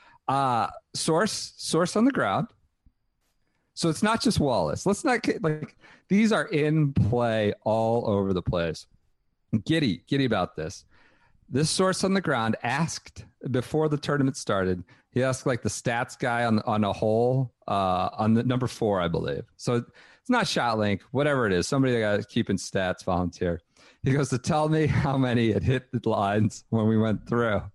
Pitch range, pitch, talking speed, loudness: 105-150 Hz, 125 Hz, 180 wpm, -26 LUFS